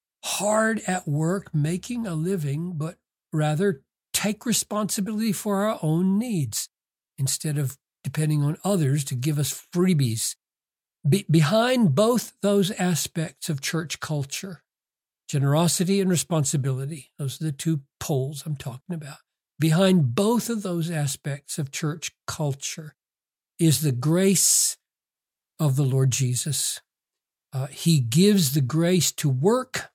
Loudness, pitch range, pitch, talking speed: -24 LUFS, 140-190 Hz, 160 Hz, 125 wpm